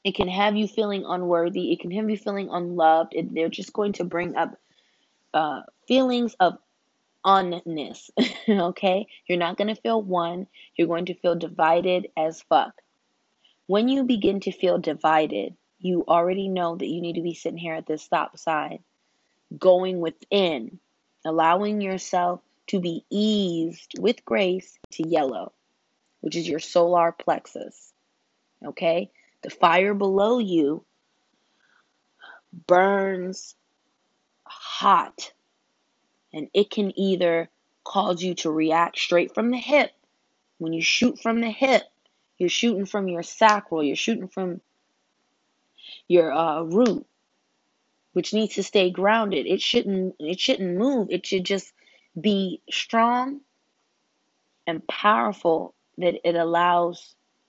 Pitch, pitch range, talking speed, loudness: 185 Hz, 170-210 Hz, 135 wpm, -24 LUFS